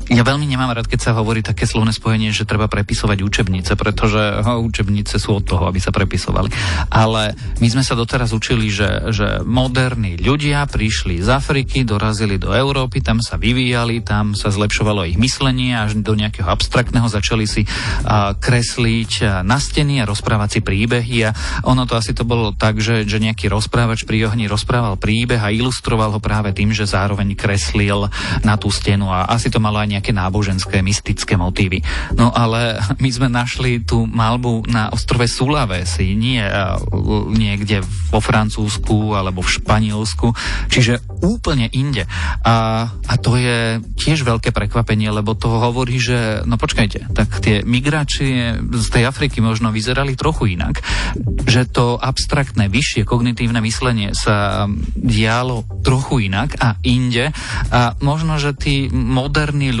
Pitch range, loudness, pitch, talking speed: 105-120 Hz, -17 LUFS, 110 Hz, 155 wpm